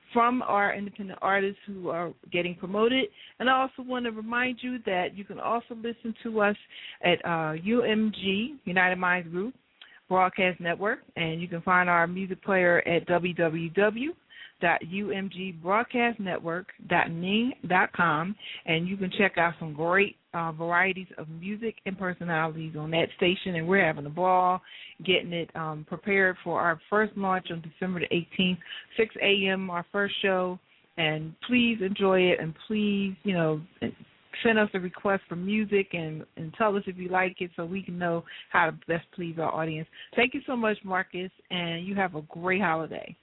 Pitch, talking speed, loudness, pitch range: 185 Hz, 175 wpm, -27 LUFS, 170-205 Hz